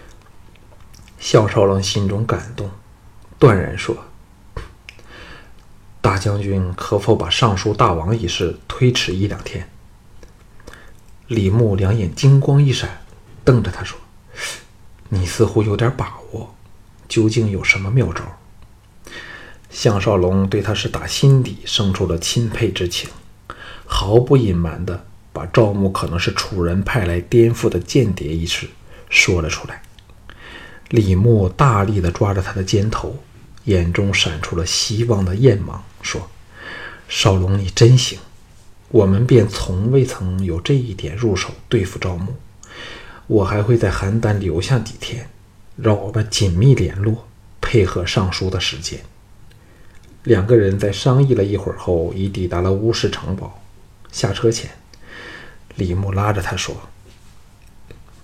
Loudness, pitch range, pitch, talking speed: -17 LUFS, 95-115 Hz, 100 Hz, 195 characters per minute